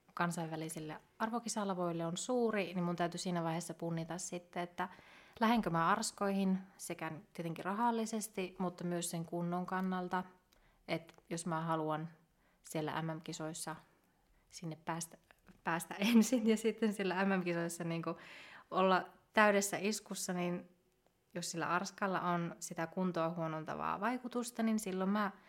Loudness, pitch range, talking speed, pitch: -37 LUFS, 165-200 Hz, 125 wpm, 180 Hz